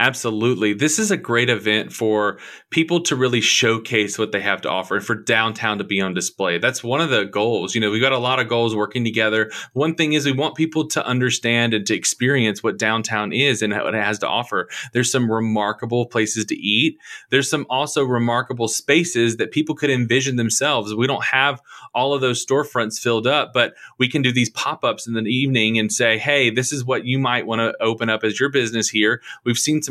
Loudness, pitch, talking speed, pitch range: -19 LUFS, 120 Hz, 225 wpm, 110-130 Hz